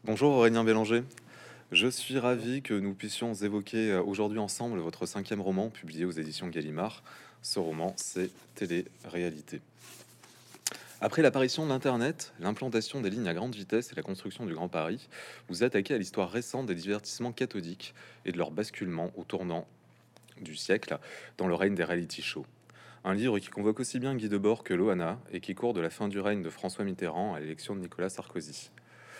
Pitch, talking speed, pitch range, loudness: 105 Hz, 180 wpm, 90-120 Hz, -32 LUFS